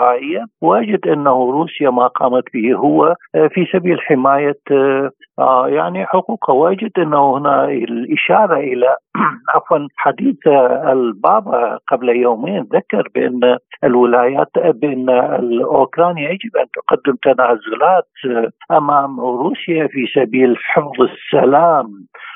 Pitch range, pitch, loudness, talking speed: 125-165 Hz, 140 Hz, -14 LUFS, 100 wpm